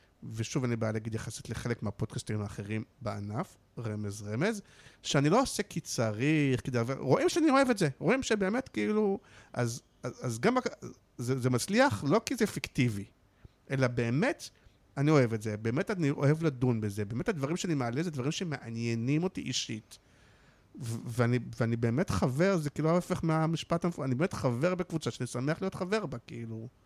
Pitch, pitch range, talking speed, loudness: 130 Hz, 115-170 Hz, 170 wpm, -31 LUFS